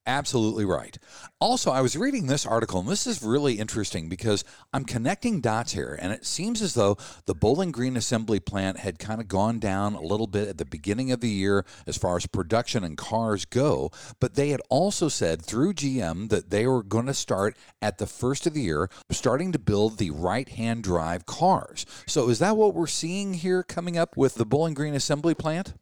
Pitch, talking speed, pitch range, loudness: 120 Hz, 210 wpm, 105-145 Hz, -26 LUFS